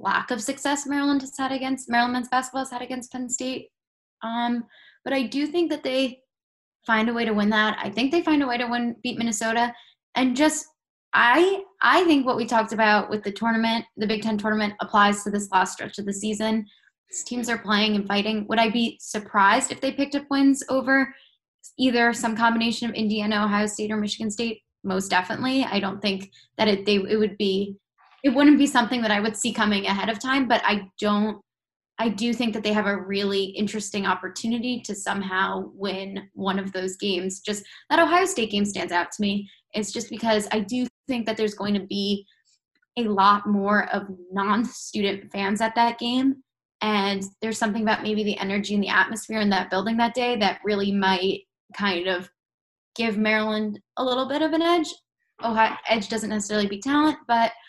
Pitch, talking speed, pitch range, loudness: 220 Hz, 205 wpm, 205-250 Hz, -24 LUFS